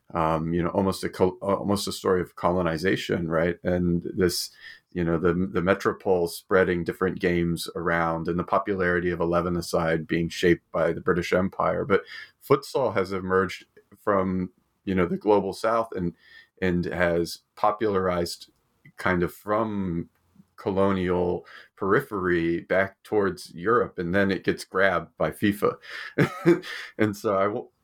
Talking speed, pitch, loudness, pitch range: 145 wpm, 90 Hz, -25 LUFS, 85-95 Hz